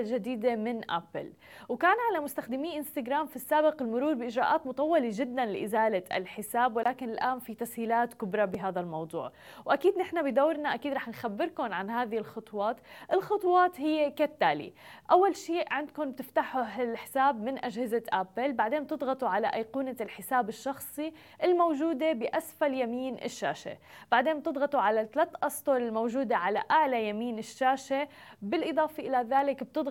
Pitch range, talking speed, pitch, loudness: 230-305 Hz, 130 wpm, 265 Hz, -30 LUFS